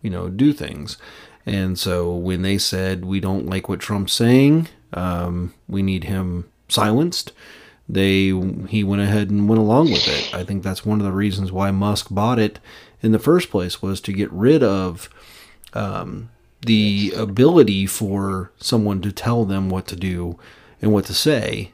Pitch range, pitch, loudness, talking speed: 95-110 Hz, 100 Hz, -19 LUFS, 175 wpm